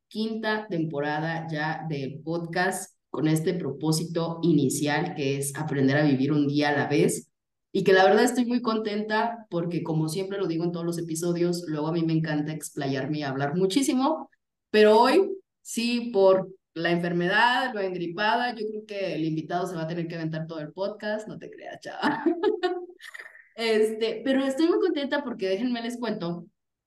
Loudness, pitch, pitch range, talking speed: -26 LUFS, 180 Hz, 160-220 Hz, 175 wpm